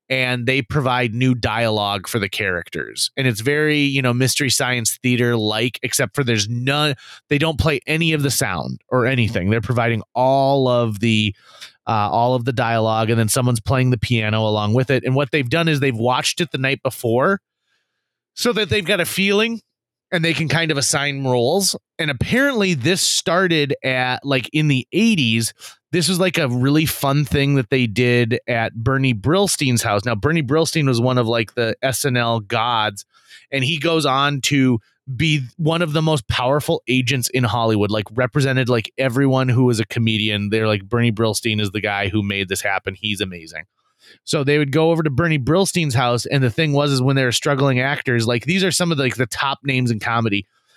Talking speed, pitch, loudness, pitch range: 205 wpm, 130 Hz, -18 LUFS, 115-145 Hz